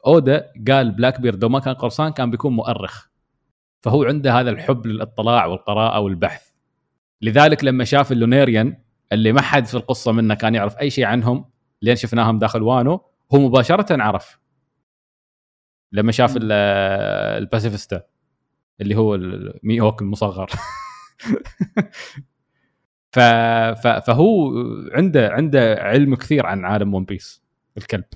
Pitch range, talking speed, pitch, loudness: 110-135 Hz, 115 wpm, 120 Hz, -18 LUFS